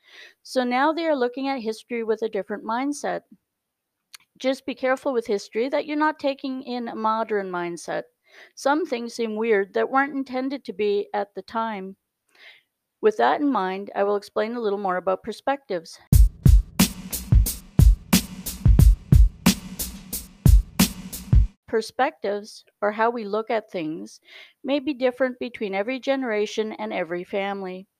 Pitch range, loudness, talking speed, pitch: 205-270 Hz, -24 LUFS, 135 wpm, 225 Hz